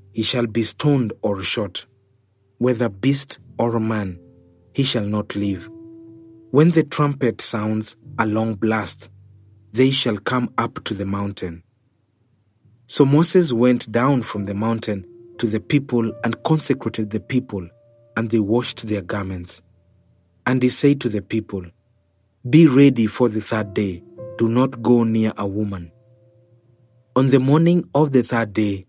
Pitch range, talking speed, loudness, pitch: 105-125 Hz, 150 wpm, -19 LUFS, 115 Hz